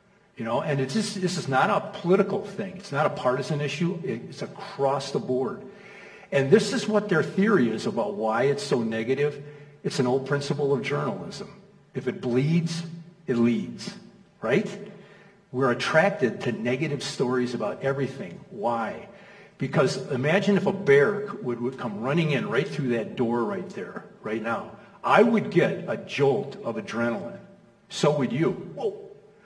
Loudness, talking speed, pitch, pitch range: -26 LUFS, 160 wpm, 195 Hz, 140-200 Hz